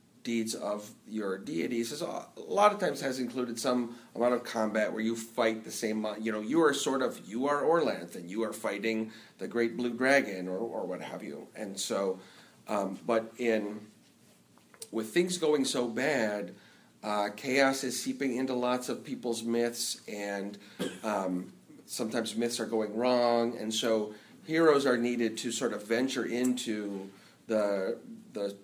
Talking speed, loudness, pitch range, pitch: 165 wpm, -31 LUFS, 105-125 Hz, 115 Hz